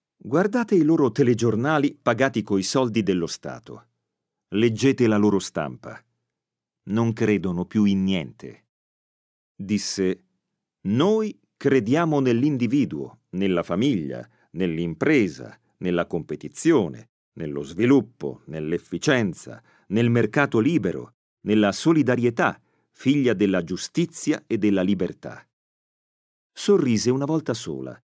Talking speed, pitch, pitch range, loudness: 95 wpm, 115 Hz, 95-140 Hz, -23 LUFS